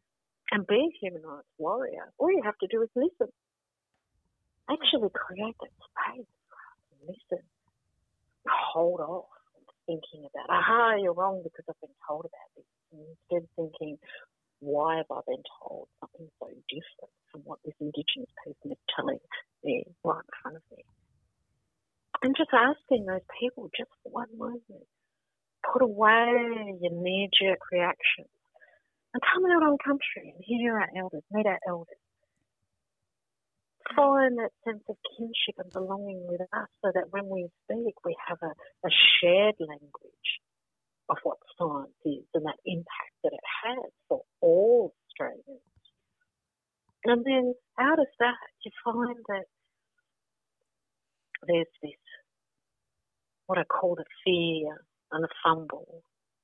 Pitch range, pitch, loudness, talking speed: 170-260 Hz, 210 Hz, -28 LUFS, 140 wpm